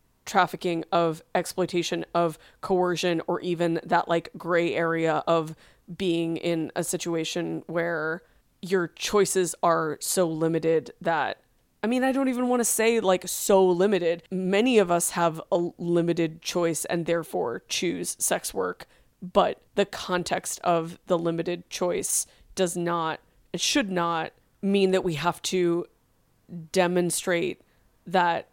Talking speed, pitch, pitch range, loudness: 135 wpm, 175 Hz, 170-185 Hz, -26 LUFS